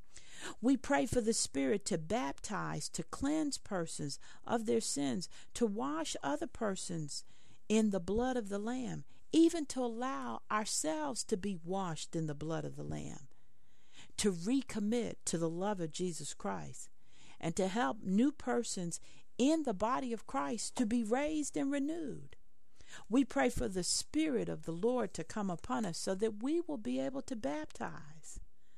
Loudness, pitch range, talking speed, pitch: -36 LUFS, 170-265 Hz, 165 wpm, 225 Hz